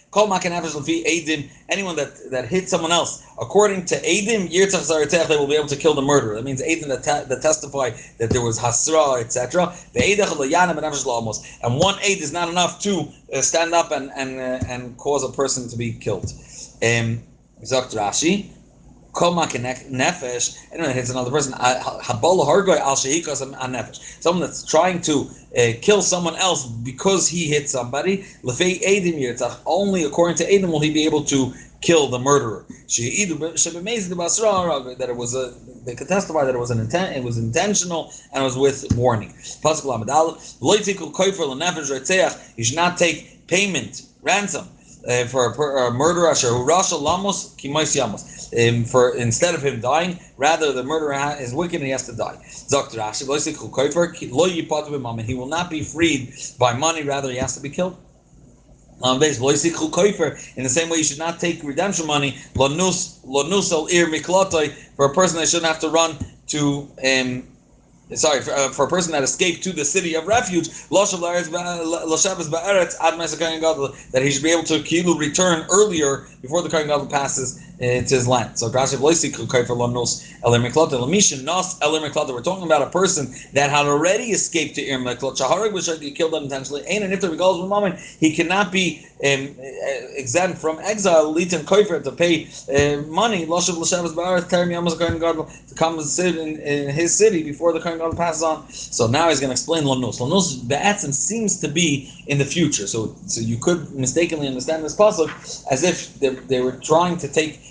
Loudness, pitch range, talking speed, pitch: -20 LUFS, 135-175 Hz, 165 wpm, 155 Hz